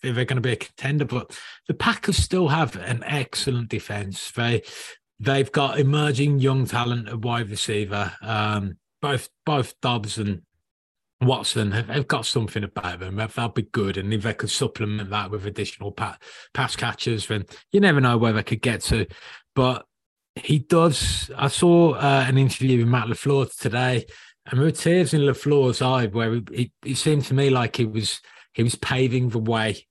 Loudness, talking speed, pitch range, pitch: -23 LUFS, 180 wpm, 110-135 Hz, 120 Hz